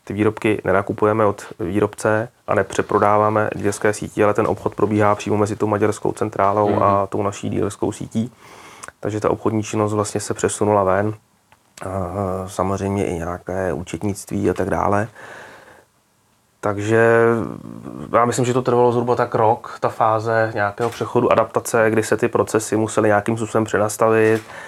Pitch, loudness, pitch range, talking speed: 105 Hz, -19 LUFS, 100-110 Hz, 145 wpm